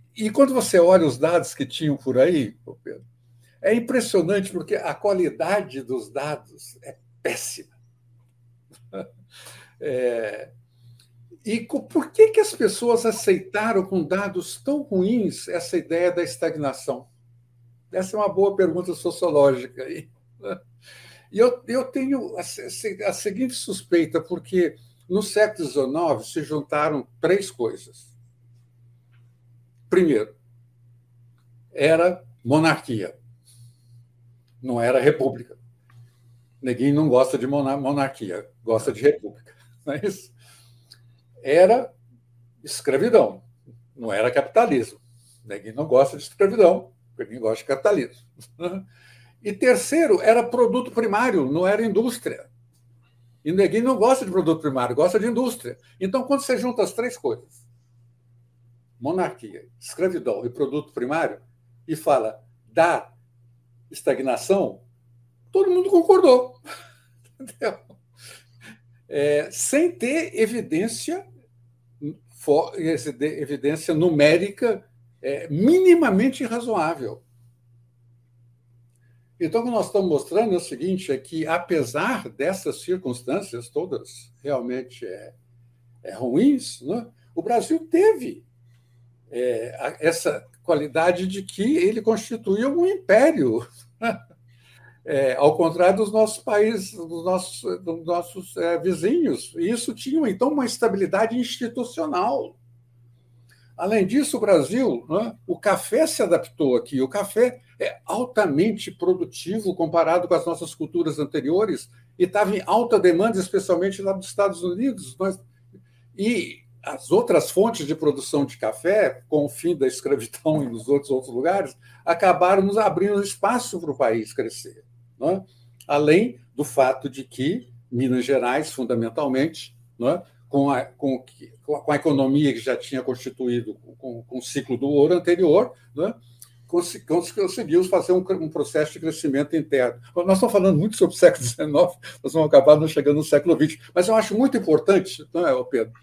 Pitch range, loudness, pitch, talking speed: 120-195 Hz, -22 LUFS, 150 Hz, 125 wpm